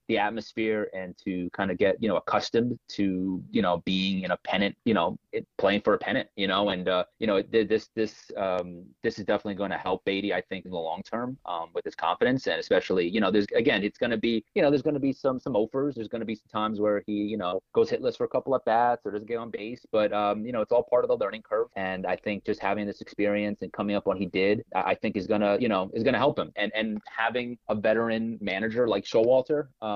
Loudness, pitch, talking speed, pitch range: -27 LUFS, 105 Hz, 275 wpm, 100-115 Hz